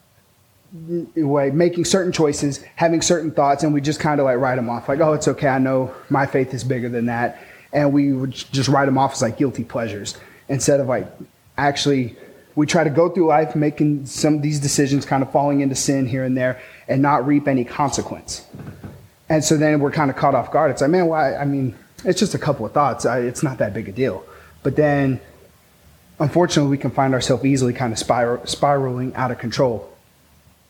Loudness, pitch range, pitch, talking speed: -19 LUFS, 125-150 Hz, 140 Hz, 210 wpm